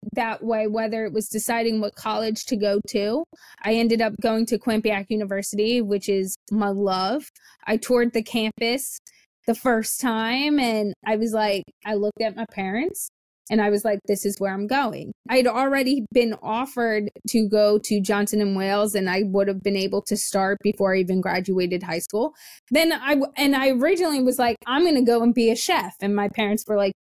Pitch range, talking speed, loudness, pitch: 205-240 Hz, 200 wpm, -23 LUFS, 220 Hz